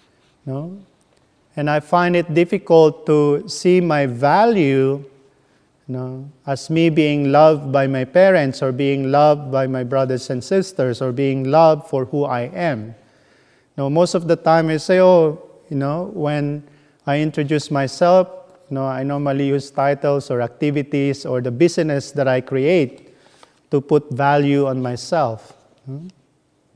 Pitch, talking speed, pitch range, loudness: 145 Hz, 160 wpm, 135-160 Hz, -17 LUFS